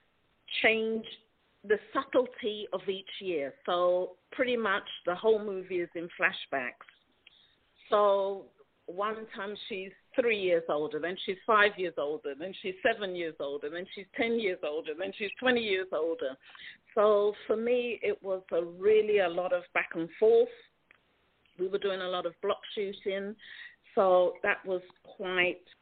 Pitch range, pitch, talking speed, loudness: 180-225 Hz, 200 Hz, 155 wpm, -31 LUFS